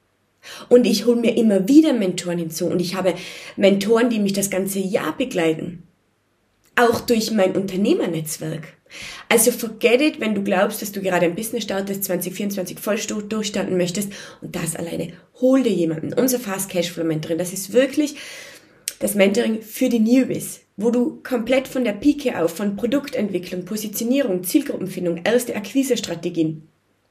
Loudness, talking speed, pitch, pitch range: -20 LUFS, 155 wpm, 200 Hz, 180-240 Hz